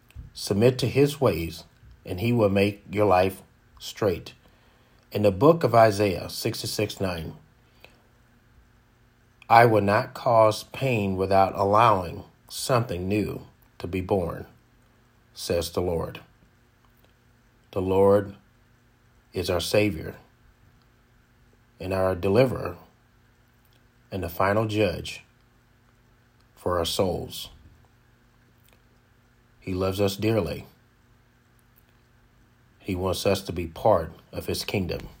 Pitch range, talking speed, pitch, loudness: 100-120 Hz, 105 wpm, 115 Hz, -24 LUFS